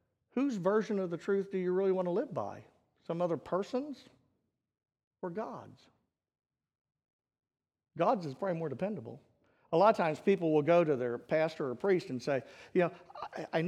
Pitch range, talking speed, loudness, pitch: 165-200 Hz, 180 wpm, -33 LUFS, 185 Hz